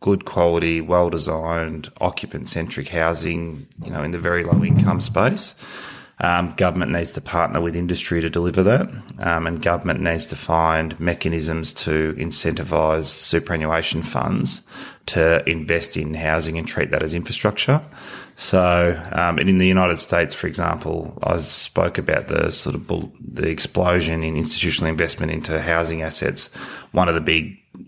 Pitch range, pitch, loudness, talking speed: 80-85 Hz, 85 Hz, -20 LUFS, 145 wpm